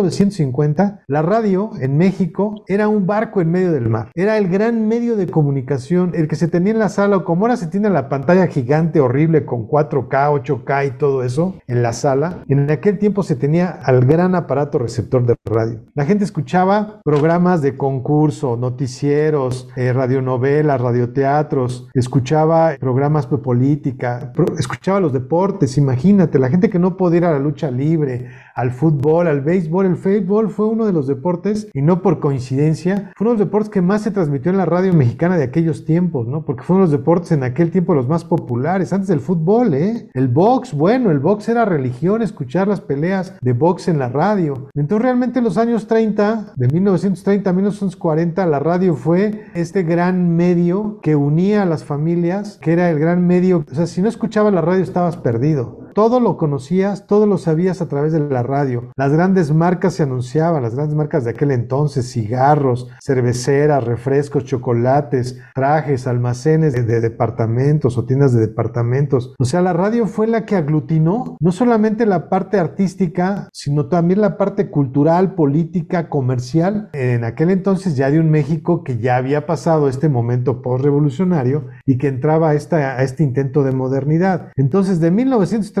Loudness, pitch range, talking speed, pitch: -17 LUFS, 140-190 Hz, 185 wpm, 160 Hz